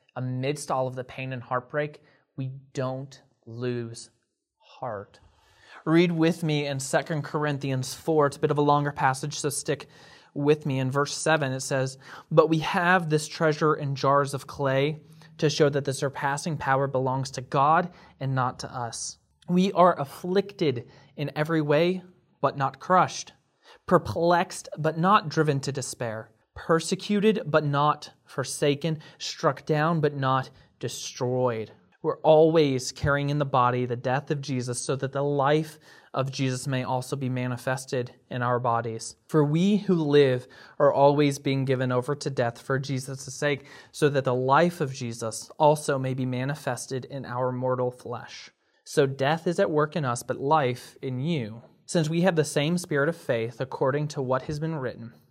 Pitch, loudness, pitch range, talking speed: 140 Hz, -26 LUFS, 130-155 Hz, 170 wpm